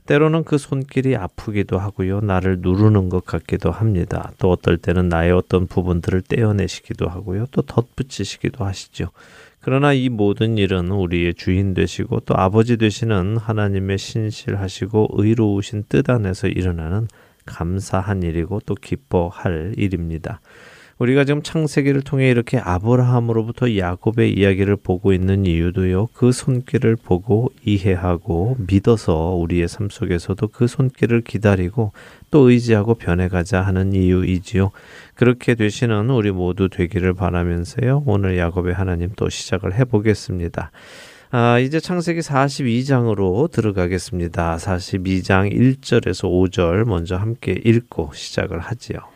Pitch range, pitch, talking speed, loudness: 90-120 Hz, 100 Hz, 325 characters per minute, -19 LUFS